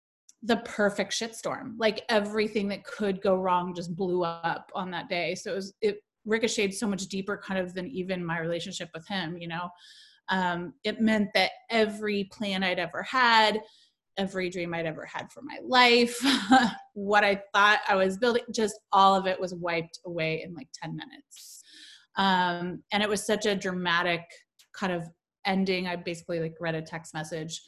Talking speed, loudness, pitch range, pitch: 180 wpm, -27 LUFS, 175-215 Hz, 195 Hz